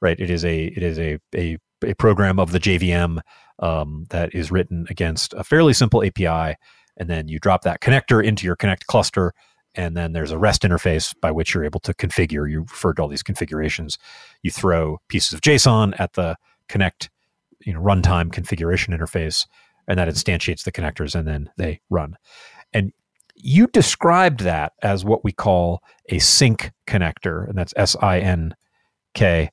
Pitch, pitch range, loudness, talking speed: 90 Hz, 80-100 Hz, -20 LUFS, 180 wpm